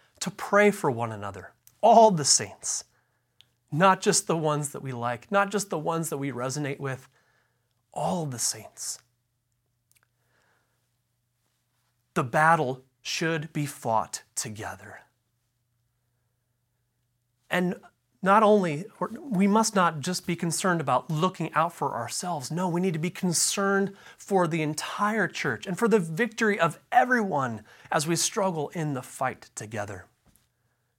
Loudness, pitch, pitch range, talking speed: -26 LUFS, 150 Hz, 120-185 Hz, 135 wpm